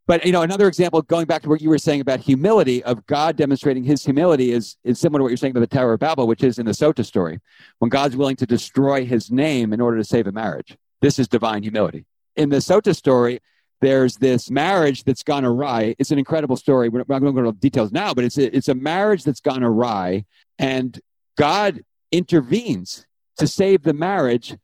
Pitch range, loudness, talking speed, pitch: 120-150 Hz, -19 LUFS, 225 wpm, 135 Hz